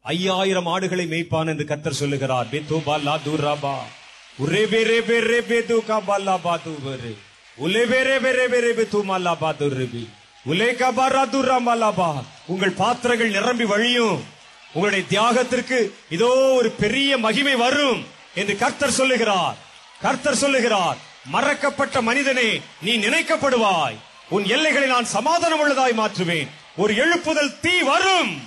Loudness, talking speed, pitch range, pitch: -20 LUFS, 135 wpm, 170-255 Hz, 225 Hz